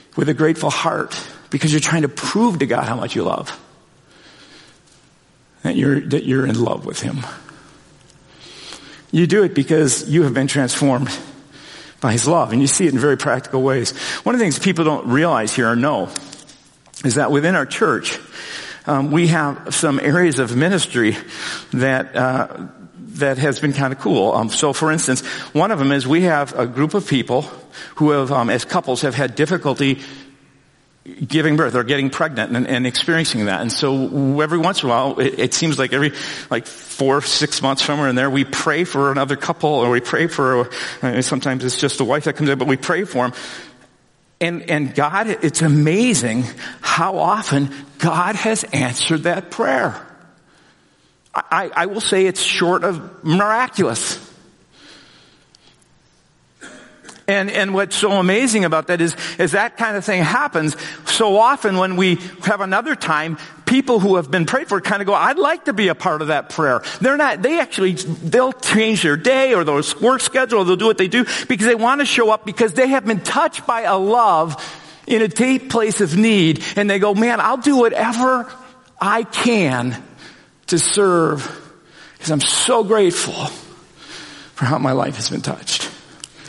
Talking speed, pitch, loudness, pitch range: 185 wpm, 160 Hz, -17 LUFS, 140-200 Hz